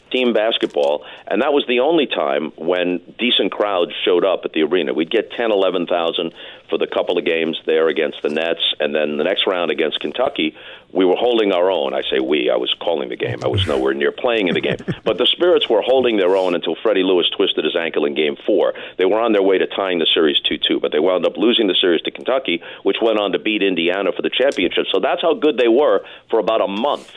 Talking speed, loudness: 245 wpm, -17 LUFS